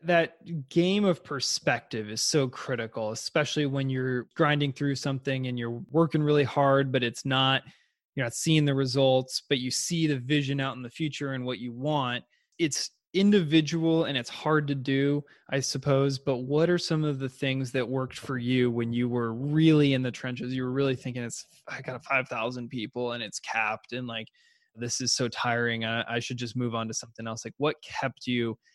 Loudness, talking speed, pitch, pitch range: -28 LUFS, 200 wpm, 135 Hz, 125-145 Hz